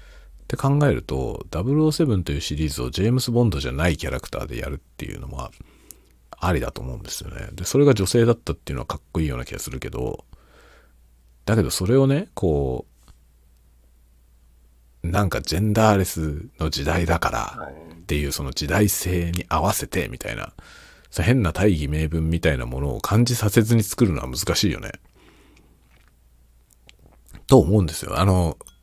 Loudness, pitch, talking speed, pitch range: -22 LUFS, 80 Hz, 335 characters per minute, 65-105 Hz